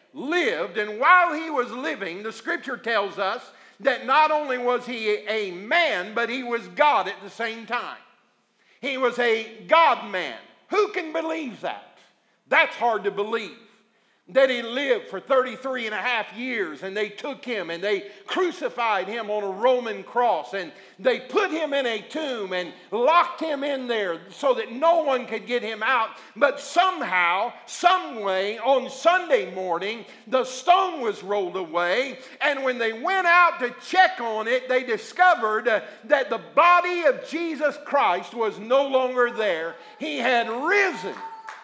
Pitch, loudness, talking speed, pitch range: 255 Hz, -23 LUFS, 165 wpm, 220-320 Hz